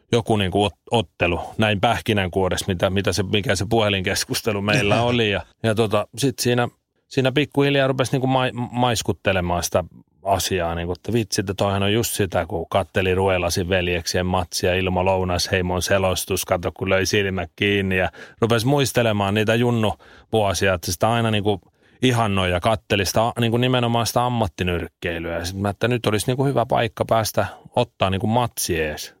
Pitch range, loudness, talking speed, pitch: 95-115 Hz, -21 LUFS, 160 wpm, 105 Hz